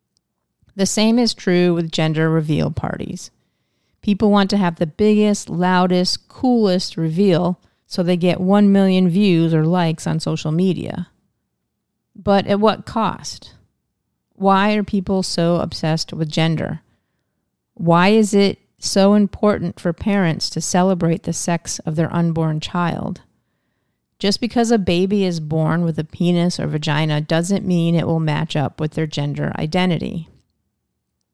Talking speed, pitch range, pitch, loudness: 145 wpm, 160-200 Hz, 175 Hz, -18 LUFS